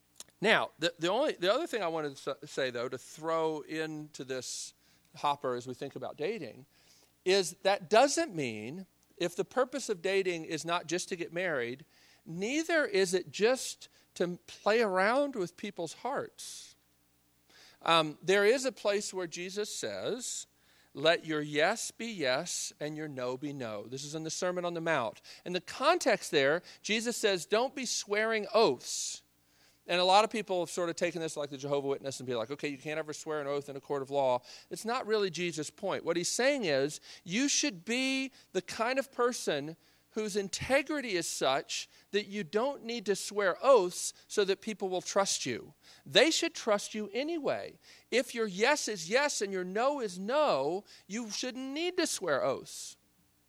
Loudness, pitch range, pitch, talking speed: -32 LUFS, 150-220 Hz, 180 Hz, 185 wpm